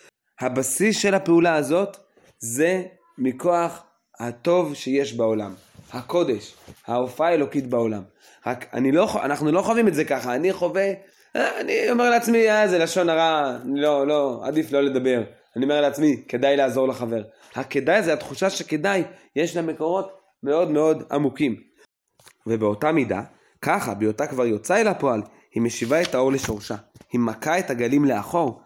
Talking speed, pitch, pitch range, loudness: 145 wpm, 145 Hz, 125-175 Hz, -22 LUFS